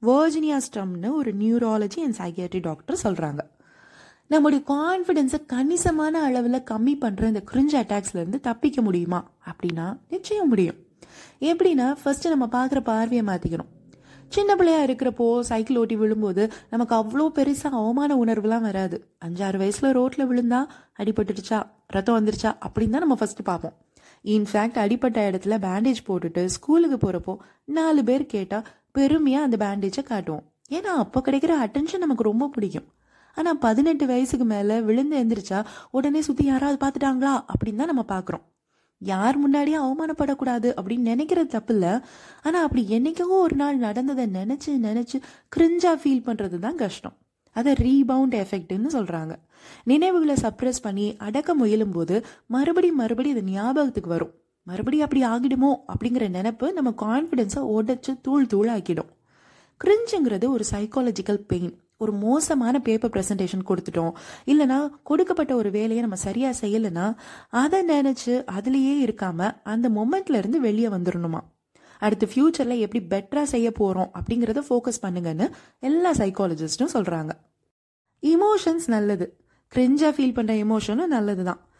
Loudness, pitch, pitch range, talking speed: -23 LUFS, 240 Hz, 210-280 Hz, 120 wpm